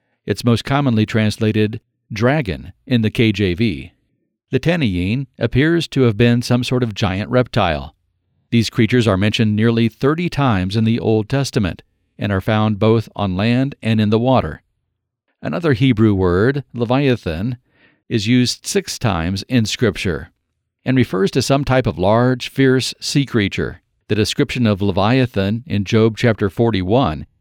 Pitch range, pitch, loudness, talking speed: 105-125 Hz, 115 Hz, -17 LUFS, 150 wpm